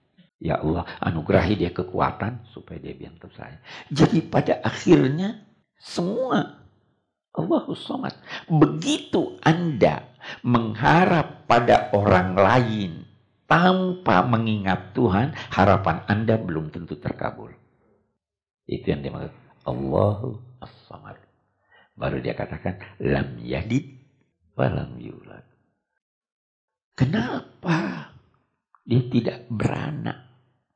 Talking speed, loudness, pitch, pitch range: 85 wpm, -23 LUFS, 120 Hz, 95-145 Hz